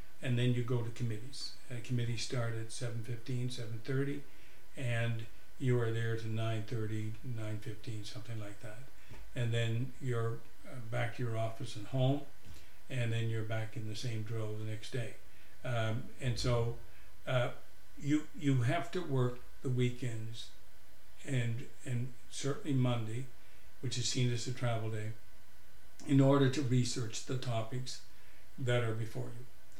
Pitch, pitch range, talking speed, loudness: 115 Hz, 110-125 Hz, 150 wpm, -37 LUFS